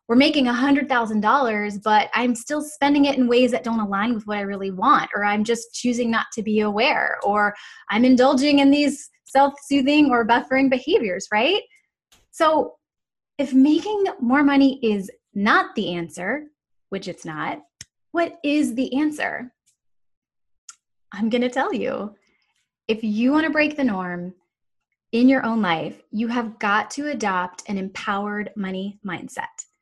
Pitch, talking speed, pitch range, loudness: 245 Hz, 155 wpm, 210-285 Hz, -21 LUFS